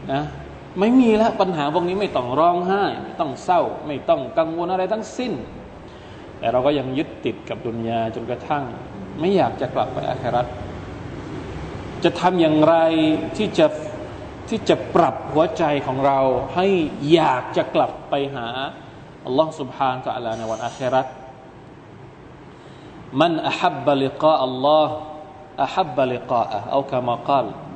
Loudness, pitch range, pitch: -21 LUFS, 130-170 Hz, 145 Hz